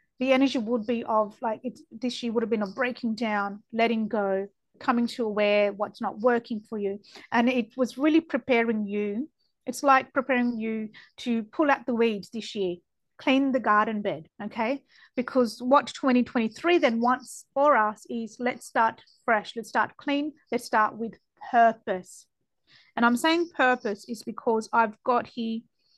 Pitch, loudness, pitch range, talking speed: 235 Hz, -26 LUFS, 220-255 Hz, 170 wpm